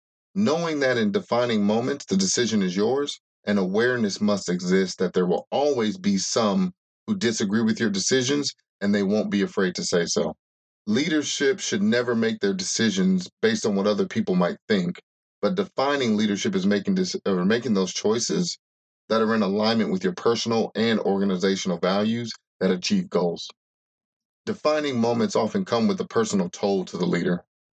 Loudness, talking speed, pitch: -24 LUFS, 170 wpm, 145 Hz